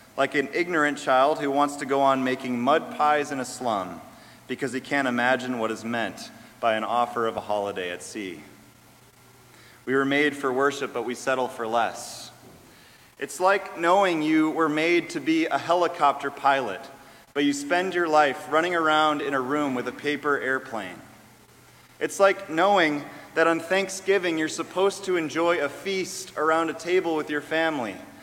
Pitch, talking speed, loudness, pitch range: 145 Hz, 175 wpm, -24 LUFS, 130-165 Hz